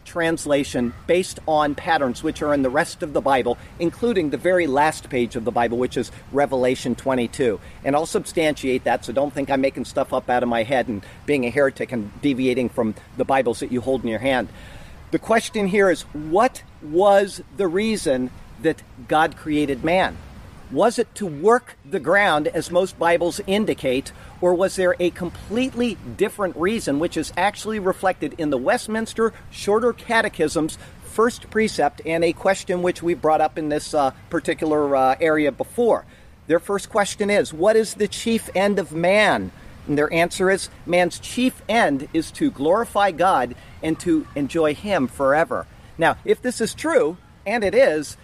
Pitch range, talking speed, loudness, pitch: 140-200 Hz, 180 wpm, -21 LUFS, 165 Hz